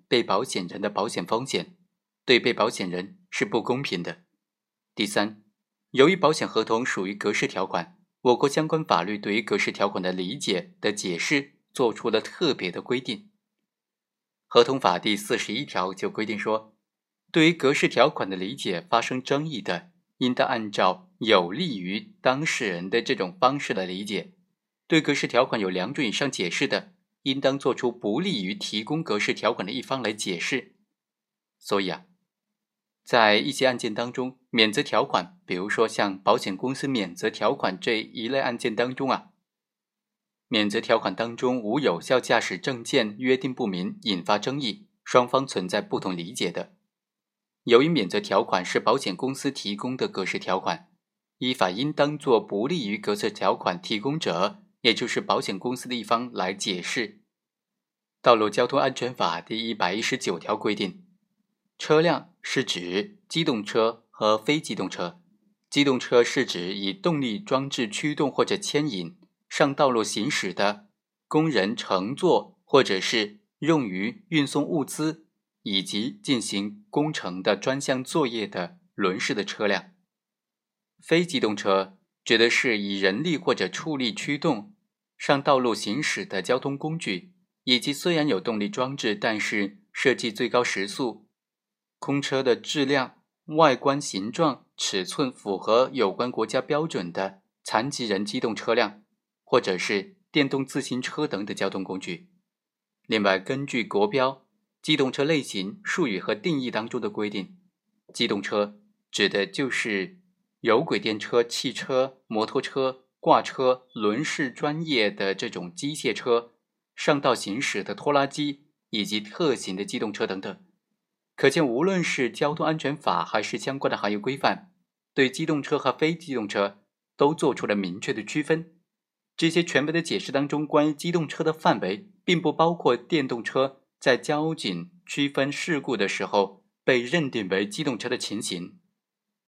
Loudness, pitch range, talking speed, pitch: -25 LUFS, 110-165 Hz, 240 characters per minute, 135 Hz